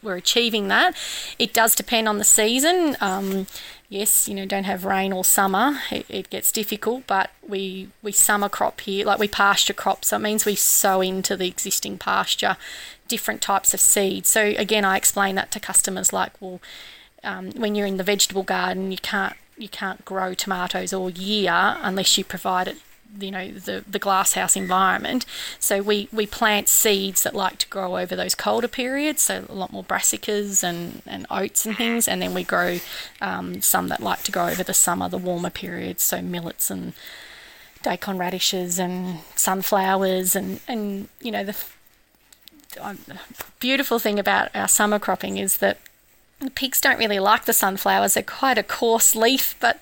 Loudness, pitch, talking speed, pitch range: -20 LUFS, 200 Hz, 185 wpm, 190-220 Hz